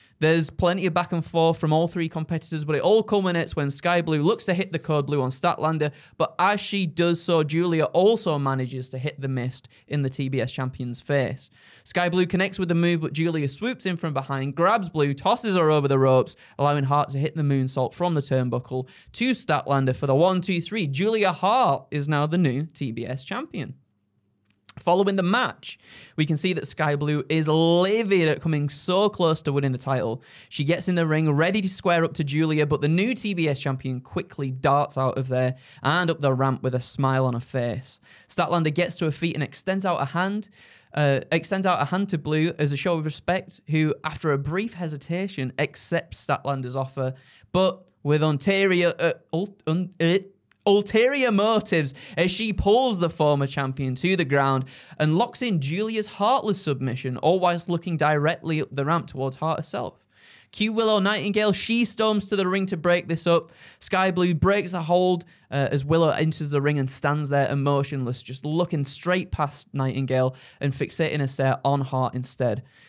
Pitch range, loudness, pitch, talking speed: 140-180 Hz, -24 LUFS, 155 Hz, 195 wpm